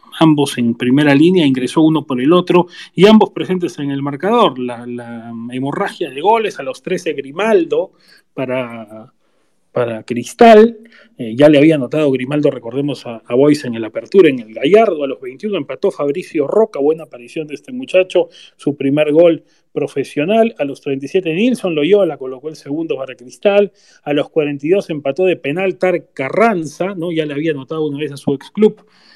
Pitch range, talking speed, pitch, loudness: 135-185 Hz, 180 wpm, 150 Hz, -15 LUFS